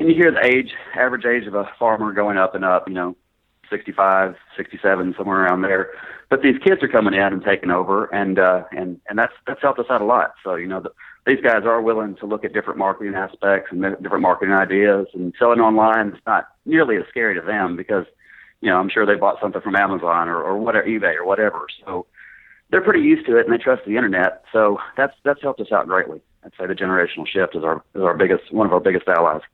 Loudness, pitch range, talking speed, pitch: -19 LUFS, 95-115 Hz, 240 wpm, 100 Hz